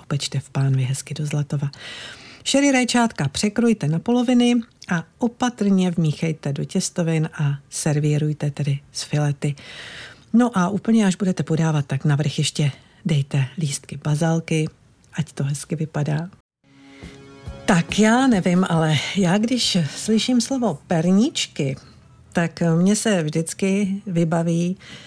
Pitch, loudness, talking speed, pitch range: 165 Hz, -21 LUFS, 120 wpm, 150-200 Hz